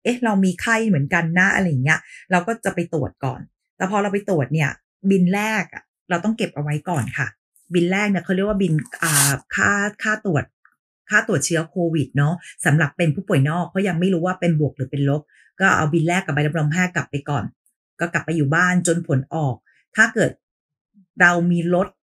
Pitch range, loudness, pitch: 150-190 Hz, -20 LUFS, 170 Hz